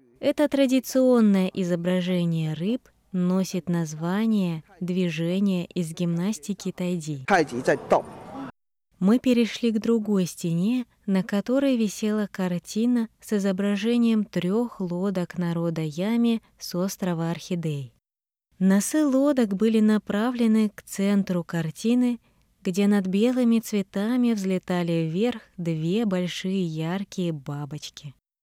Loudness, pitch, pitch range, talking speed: -25 LUFS, 195 Hz, 175-225 Hz, 95 wpm